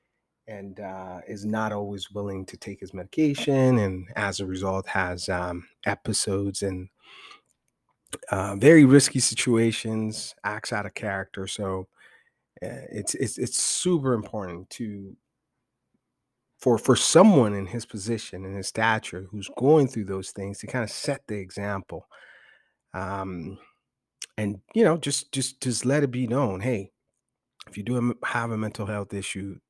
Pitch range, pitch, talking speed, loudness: 95-120 Hz, 105 Hz, 150 wpm, -25 LUFS